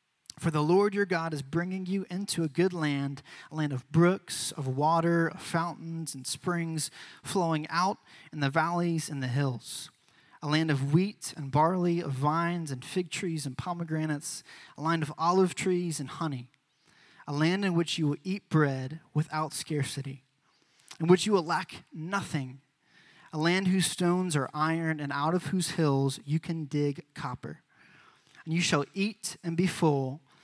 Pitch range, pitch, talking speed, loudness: 145-175 Hz, 160 Hz, 175 wpm, -30 LUFS